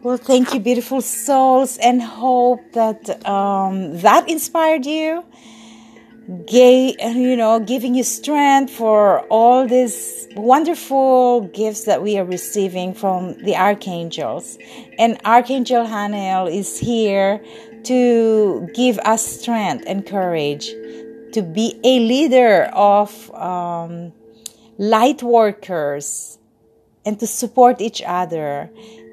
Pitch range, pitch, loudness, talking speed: 195-250 Hz, 225 Hz, -16 LUFS, 110 wpm